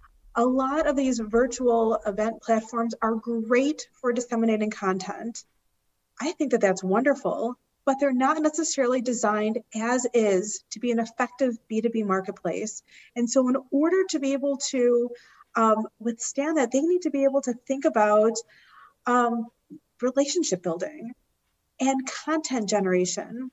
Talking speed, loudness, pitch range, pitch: 140 wpm, -25 LUFS, 220-270 Hz, 240 Hz